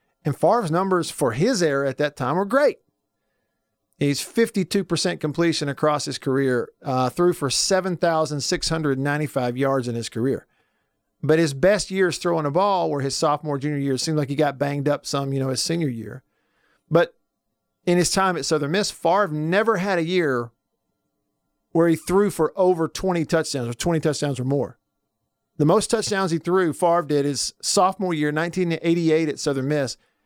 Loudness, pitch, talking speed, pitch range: -22 LUFS, 155 Hz, 175 wpm, 140-175 Hz